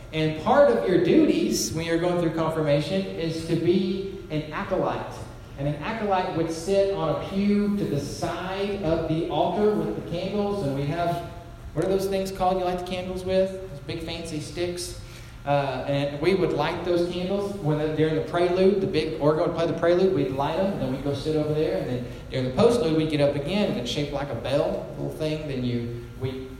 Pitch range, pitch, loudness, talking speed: 145-185 Hz, 165 Hz, -25 LUFS, 215 wpm